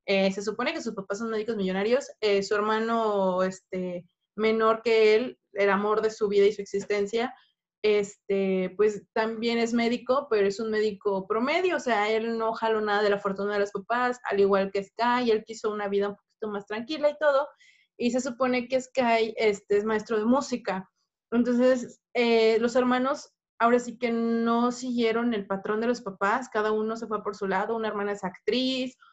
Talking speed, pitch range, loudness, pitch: 195 wpm, 200-240 Hz, -26 LUFS, 220 Hz